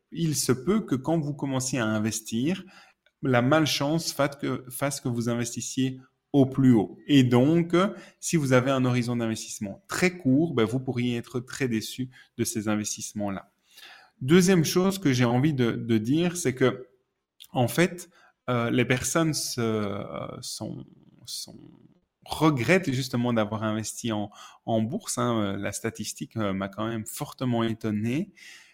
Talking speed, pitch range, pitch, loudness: 150 wpm, 115-145 Hz, 125 Hz, -26 LUFS